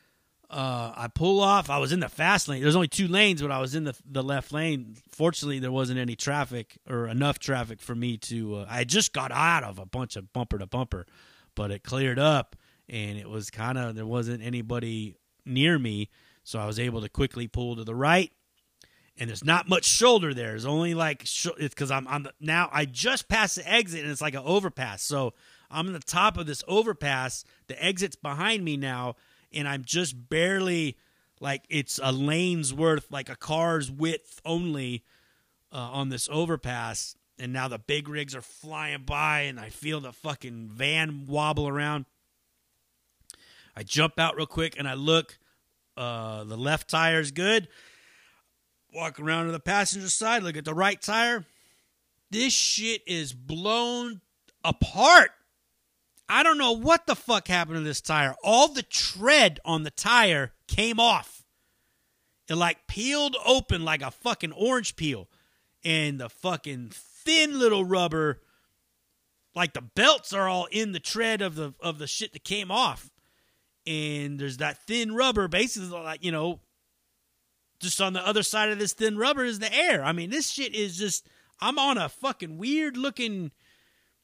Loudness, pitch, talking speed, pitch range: -26 LUFS, 155 Hz, 180 wpm, 130-190 Hz